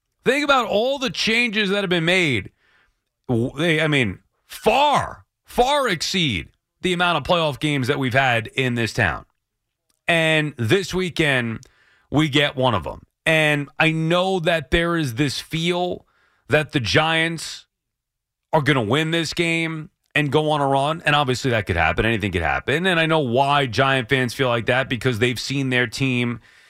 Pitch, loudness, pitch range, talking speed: 150 Hz, -20 LUFS, 125-165 Hz, 175 wpm